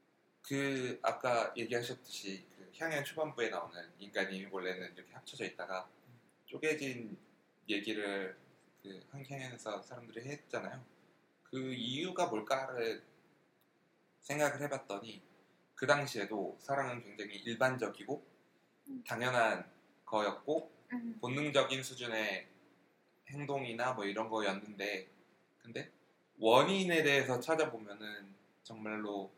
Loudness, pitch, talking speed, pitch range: -37 LUFS, 125 Hz, 255 characters per minute, 100-145 Hz